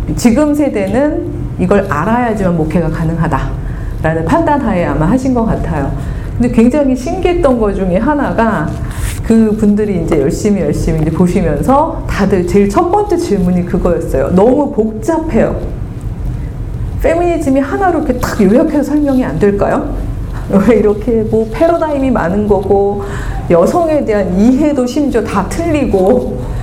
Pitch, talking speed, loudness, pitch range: 220 Hz, 315 characters per minute, -12 LUFS, 185-285 Hz